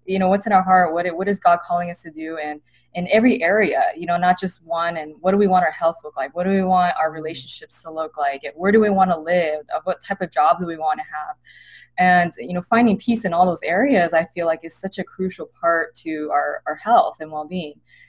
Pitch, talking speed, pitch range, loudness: 175 Hz, 270 wpm, 160-190 Hz, -20 LUFS